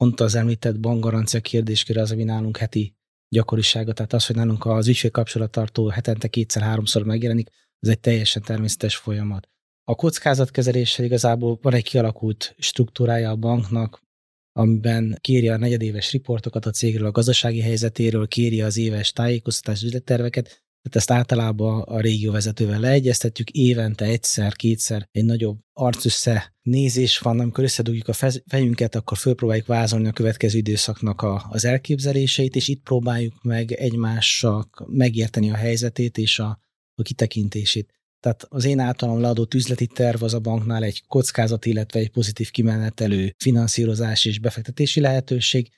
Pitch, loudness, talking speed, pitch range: 115 Hz, -21 LUFS, 140 wpm, 110-120 Hz